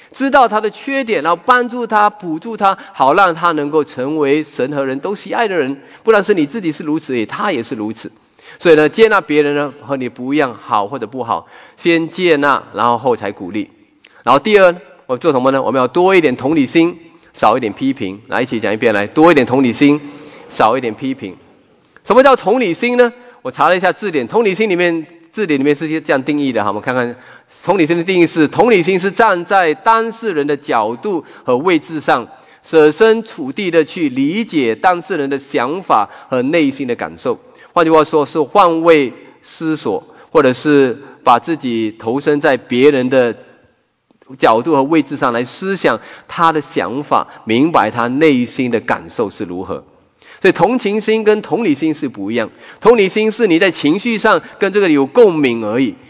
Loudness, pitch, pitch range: -14 LUFS, 165 Hz, 145-220 Hz